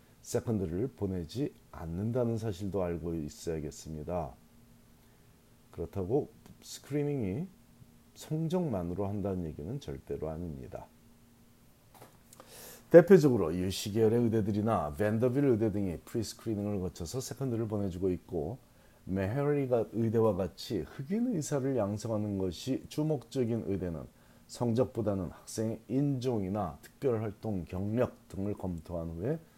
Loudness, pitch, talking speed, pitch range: -32 LUFS, 105 Hz, 290 characters per minute, 90-120 Hz